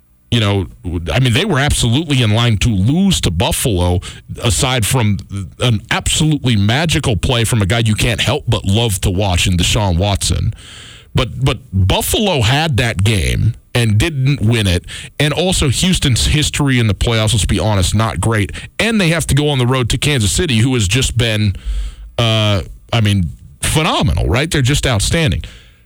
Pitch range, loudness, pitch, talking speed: 100-130 Hz, -14 LUFS, 115 Hz, 170 wpm